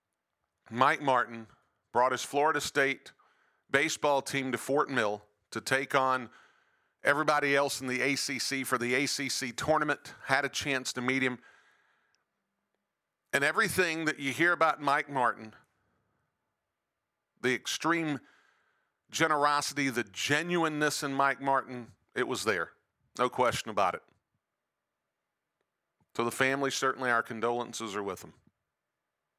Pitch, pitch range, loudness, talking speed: 135 Hz, 120-145 Hz, -30 LUFS, 125 wpm